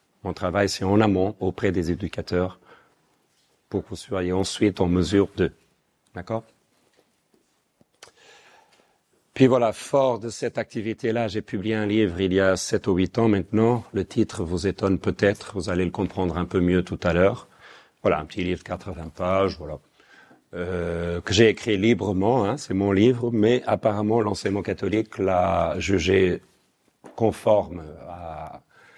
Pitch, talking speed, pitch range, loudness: 95 Hz, 155 wpm, 90-110 Hz, -23 LUFS